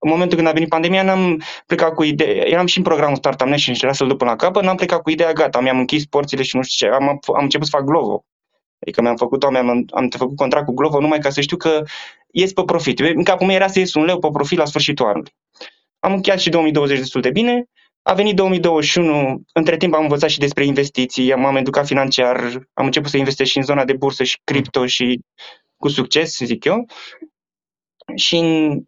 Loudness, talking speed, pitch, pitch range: -16 LUFS, 220 wpm, 150 Hz, 135-170 Hz